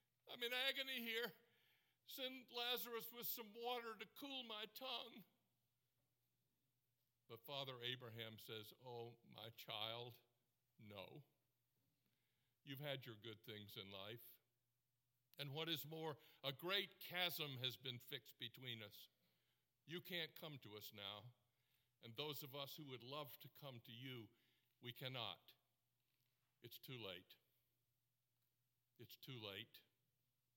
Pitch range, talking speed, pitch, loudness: 120-150 Hz, 130 wpm, 125 Hz, -51 LUFS